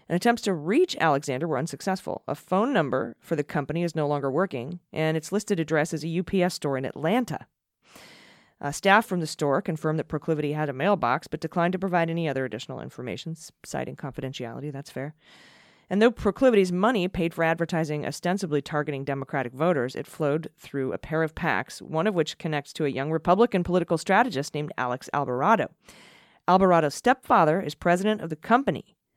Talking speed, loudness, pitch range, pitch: 180 wpm, -26 LUFS, 145-185 Hz, 160 Hz